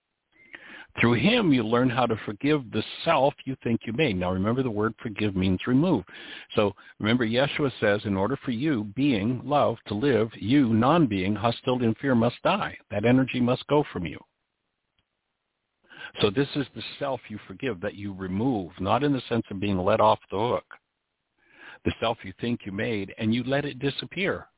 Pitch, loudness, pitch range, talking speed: 120 Hz, -26 LUFS, 105-135 Hz, 185 wpm